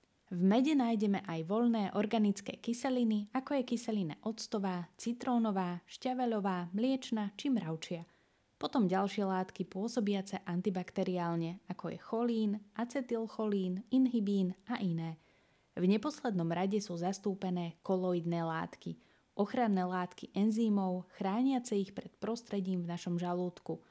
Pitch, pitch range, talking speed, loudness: 200 Hz, 180-230 Hz, 115 wpm, -35 LUFS